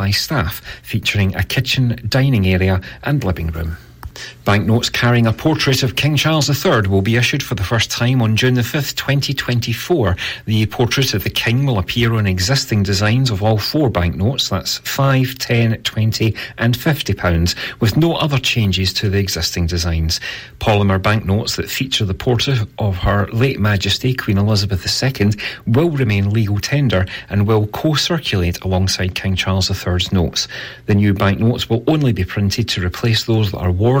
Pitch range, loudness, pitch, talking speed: 100-130 Hz, -16 LUFS, 110 Hz, 170 wpm